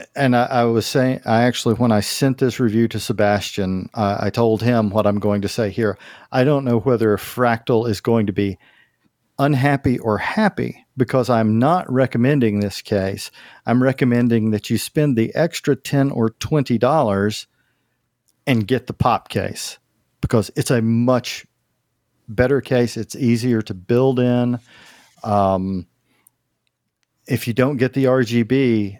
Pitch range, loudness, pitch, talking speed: 110-130 Hz, -19 LUFS, 120 Hz, 155 wpm